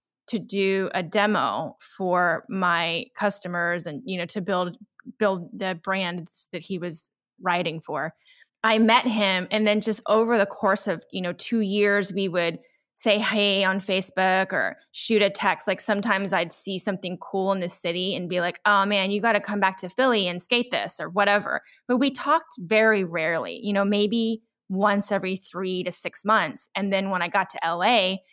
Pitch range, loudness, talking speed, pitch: 180-215 Hz, -23 LUFS, 195 wpm, 195 Hz